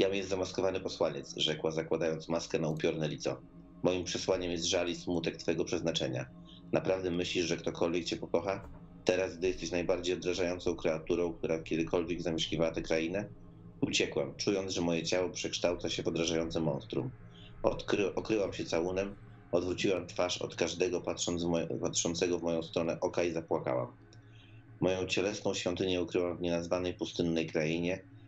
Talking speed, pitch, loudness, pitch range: 155 wpm, 85 Hz, -33 LUFS, 80-95 Hz